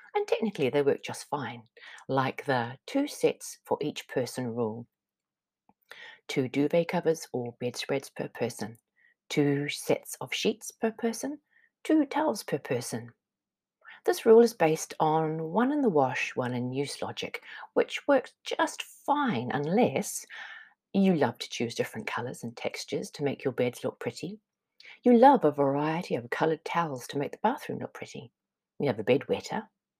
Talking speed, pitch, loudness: 160 wpm, 175 Hz, -29 LUFS